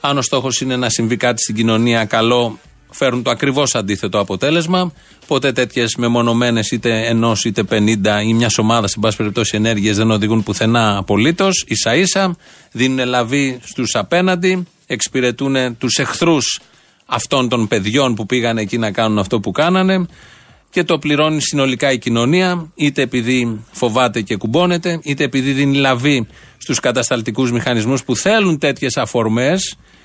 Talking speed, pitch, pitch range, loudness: 150 wpm, 125 Hz, 115-140 Hz, -15 LUFS